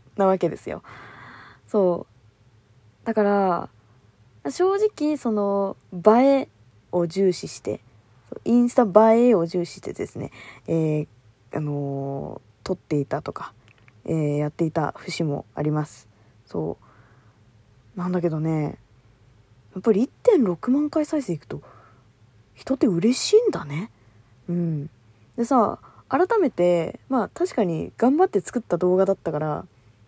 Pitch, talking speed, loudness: 165 Hz, 225 characters per minute, -23 LUFS